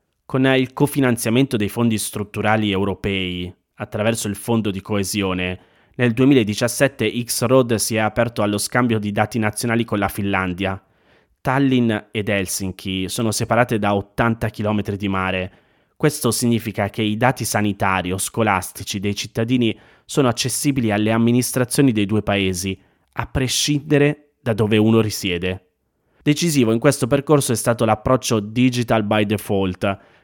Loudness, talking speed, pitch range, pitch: -19 LUFS, 135 wpm, 100-125 Hz, 110 Hz